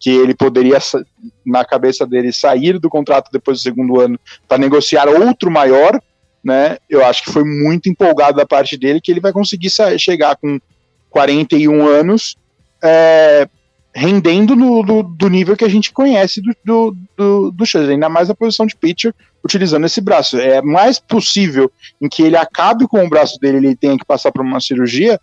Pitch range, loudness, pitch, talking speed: 135-200 Hz, -12 LUFS, 160 Hz, 190 wpm